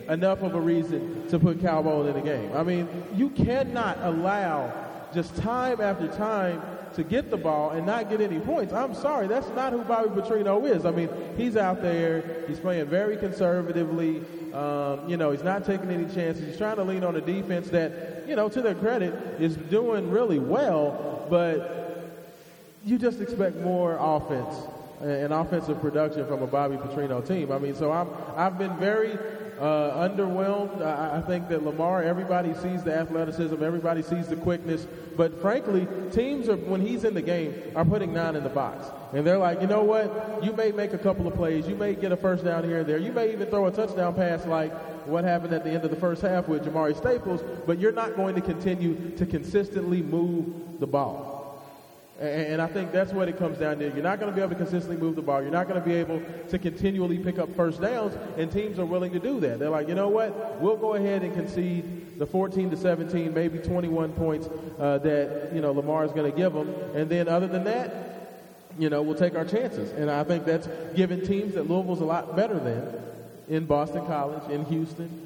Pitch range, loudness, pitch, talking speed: 160-190 Hz, -27 LUFS, 170 Hz, 215 wpm